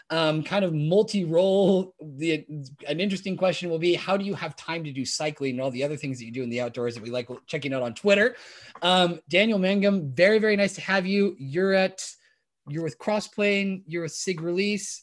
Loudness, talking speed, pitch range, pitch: -25 LUFS, 215 wpm, 150-195 Hz, 175 Hz